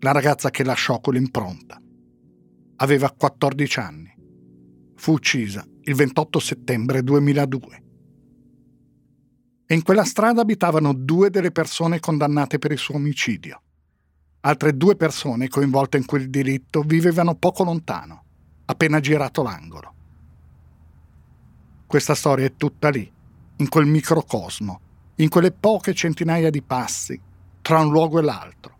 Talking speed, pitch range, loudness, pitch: 125 wpm, 100-155 Hz, -20 LUFS, 140 Hz